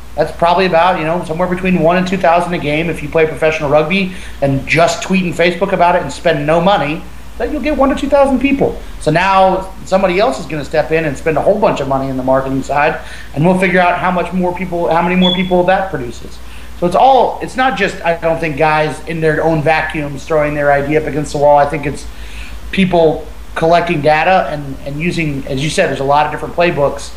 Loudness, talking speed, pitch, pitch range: -13 LUFS, 240 wpm, 160 Hz, 150-180 Hz